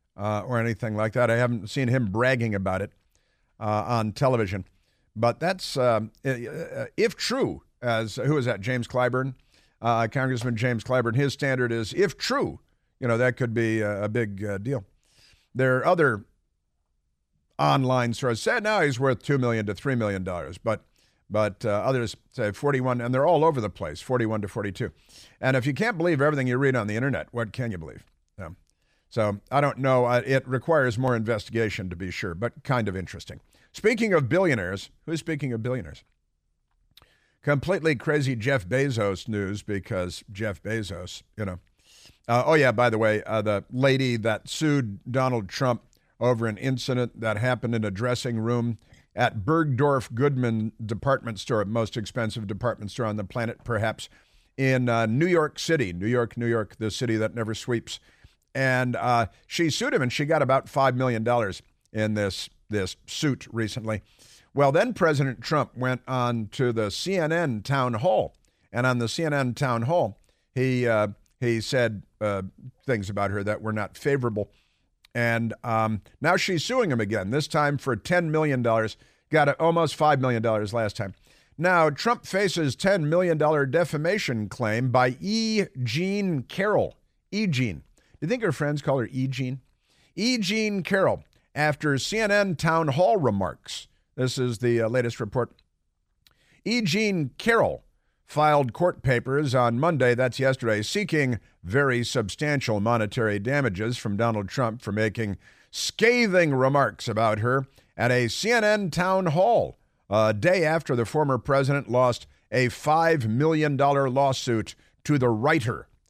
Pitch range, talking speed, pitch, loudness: 110-140 Hz, 165 wpm, 125 Hz, -25 LUFS